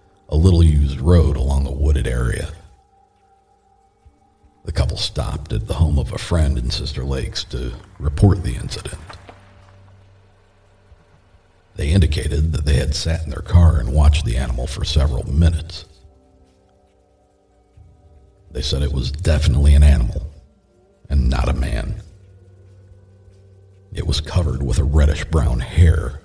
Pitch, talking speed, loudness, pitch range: 80 Hz, 135 wpm, -19 LUFS, 70-95 Hz